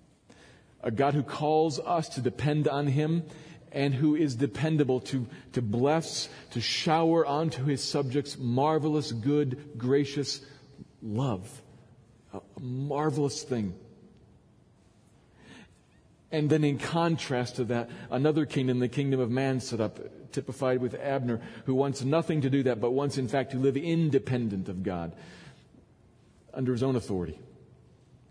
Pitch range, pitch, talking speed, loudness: 125-150 Hz, 135 Hz, 135 wpm, -29 LUFS